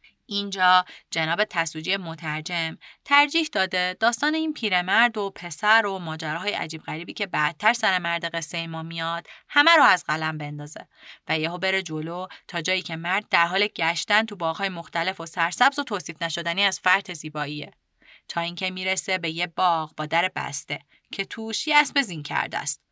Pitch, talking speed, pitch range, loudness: 180 Hz, 175 wpm, 165-205 Hz, -24 LUFS